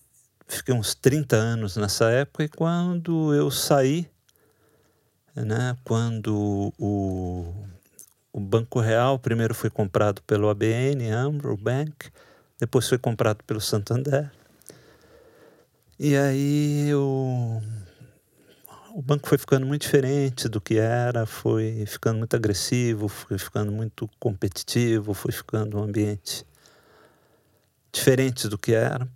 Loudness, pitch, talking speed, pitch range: -24 LUFS, 115 Hz, 115 wpm, 110-135 Hz